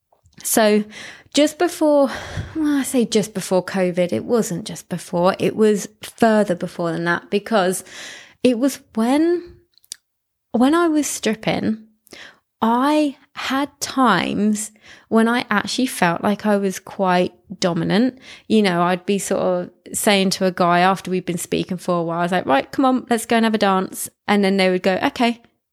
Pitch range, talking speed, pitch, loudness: 185-250 Hz, 175 wpm, 210 Hz, -19 LUFS